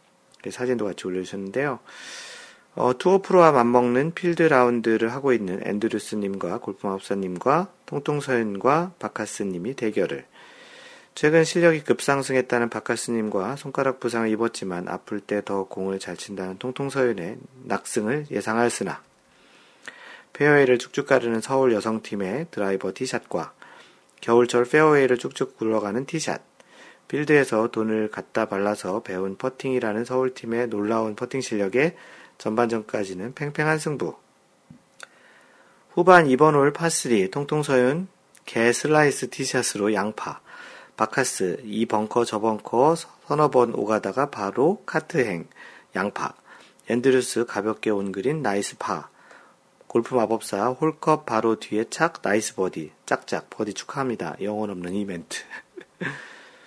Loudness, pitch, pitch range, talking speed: -23 LUFS, 120 Hz, 105-140 Hz, 300 characters per minute